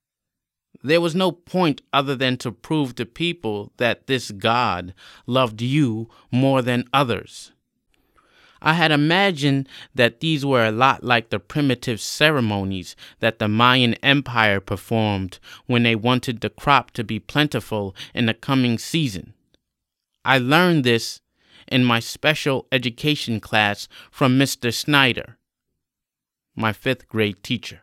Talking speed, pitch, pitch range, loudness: 135 wpm, 125 Hz, 110-140 Hz, -20 LUFS